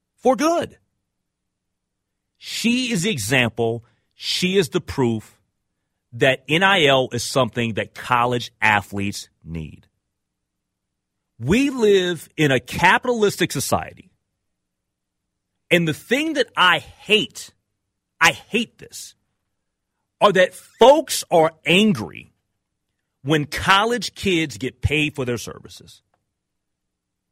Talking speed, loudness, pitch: 100 wpm, -19 LUFS, 140 Hz